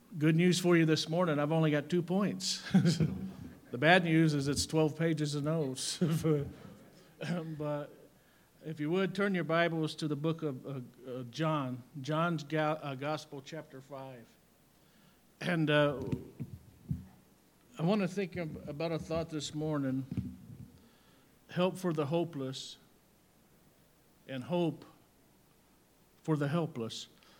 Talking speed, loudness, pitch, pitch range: 125 wpm, -33 LUFS, 155 Hz, 140-170 Hz